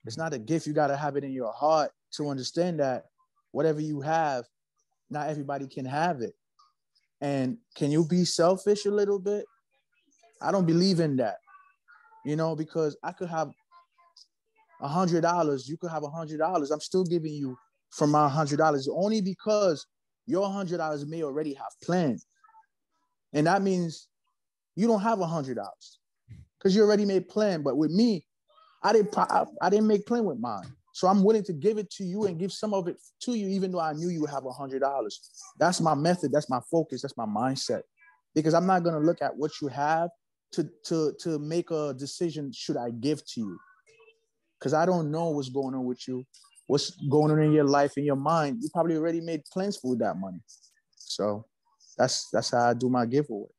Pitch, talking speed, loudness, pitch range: 165 Hz, 205 wpm, -28 LUFS, 145-205 Hz